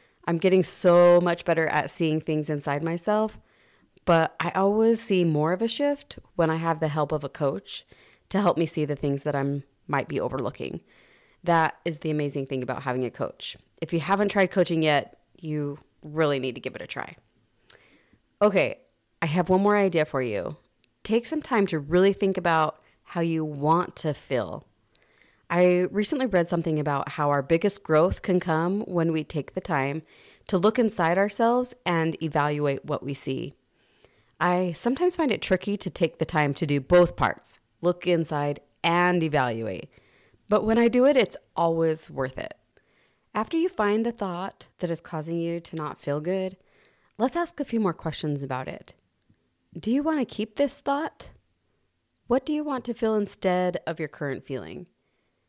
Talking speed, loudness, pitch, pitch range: 185 wpm, -25 LUFS, 170 Hz, 150-200 Hz